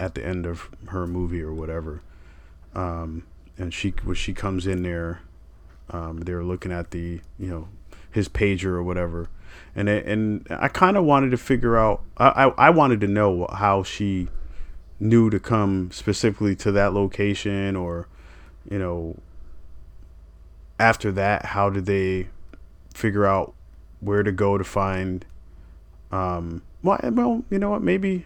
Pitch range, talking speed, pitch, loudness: 80-100 Hz, 155 wpm, 90 Hz, -23 LUFS